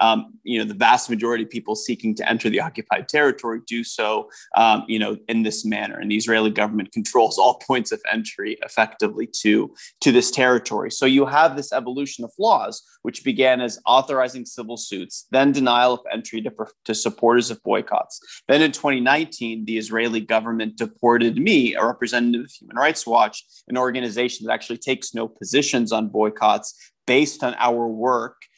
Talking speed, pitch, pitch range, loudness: 180 wpm, 120 Hz, 110-130 Hz, -20 LUFS